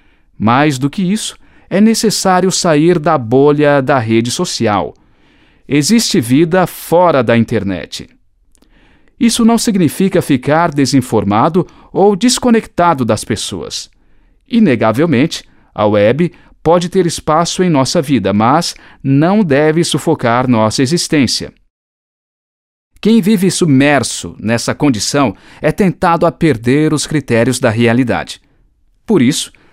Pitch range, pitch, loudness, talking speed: 125-180 Hz, 155 Hz, -12 LUFS, 115 wpm